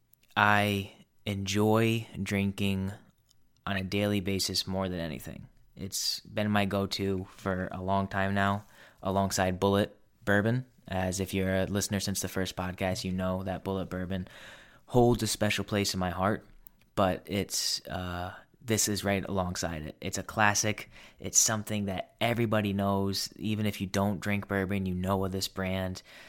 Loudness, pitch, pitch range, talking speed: -30 LUFS, 100 Hz, 95-105 Hz, 160 wpm